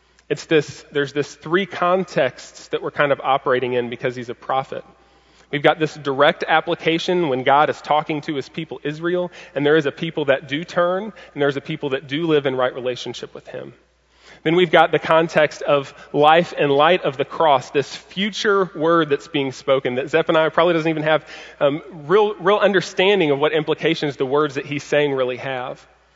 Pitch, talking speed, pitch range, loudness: 155 Hz, 200 wpm, 140-170 Hz, -19 LUFS